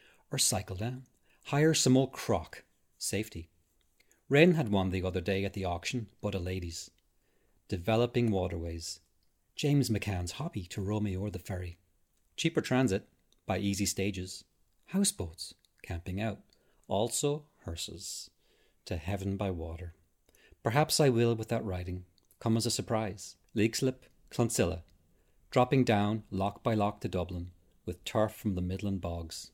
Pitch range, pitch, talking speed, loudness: 90-115 Hz, 100 Hz, 140 wpm, -32 LUFS